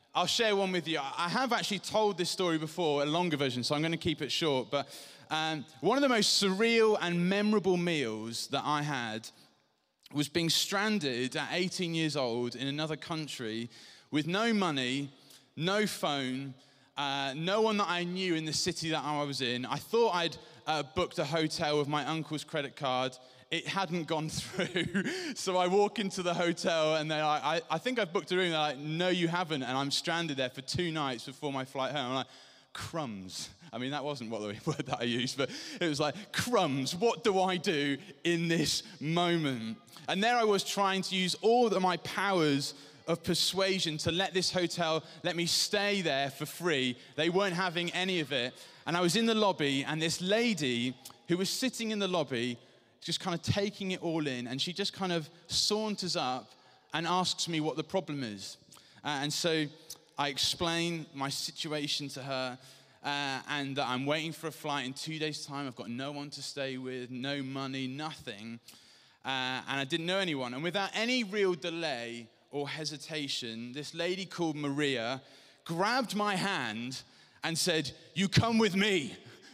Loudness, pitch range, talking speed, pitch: -32 LUFS, 135-180 Hz, 195 wpm, 155 Hz